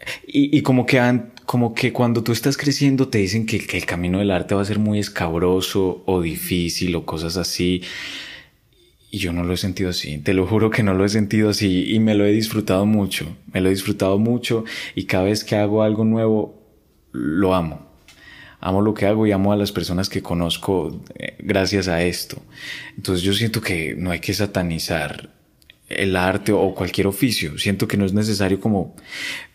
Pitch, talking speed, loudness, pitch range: 100 Hz, 200 wpm, -20 LUFS, 90-110 Hz